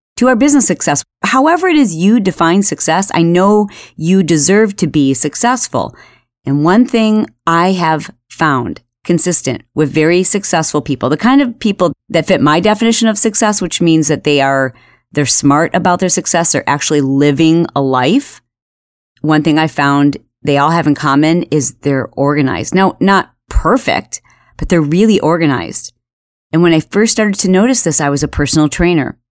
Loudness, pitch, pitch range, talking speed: -11 LUFS, 165 Hz, 145-195 Hz, 170 wpm